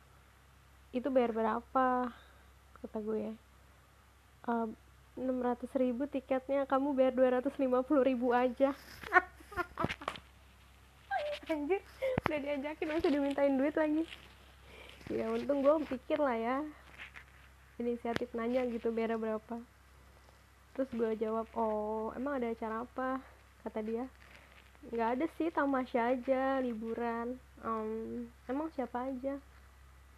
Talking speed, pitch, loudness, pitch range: 105 wpm, 255 Hz, -35 LUFS, 230-280 Hz